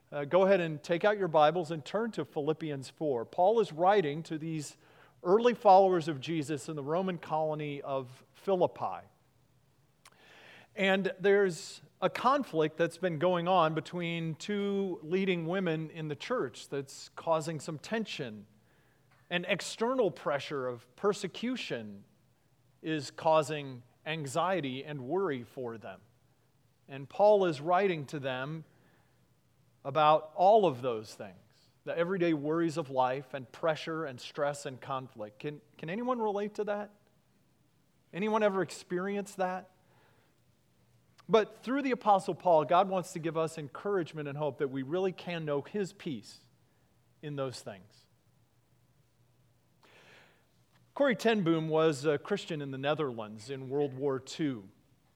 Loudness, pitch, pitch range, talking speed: -31 LUFS, 155 Hz, 140-185 Hz, 135 wpm